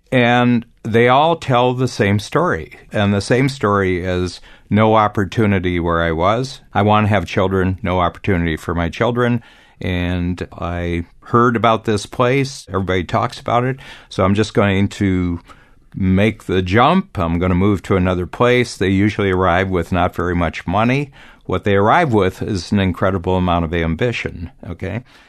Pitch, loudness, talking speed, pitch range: 100 Hz, -17 LUFS, 170 wpm, 90-120 Hz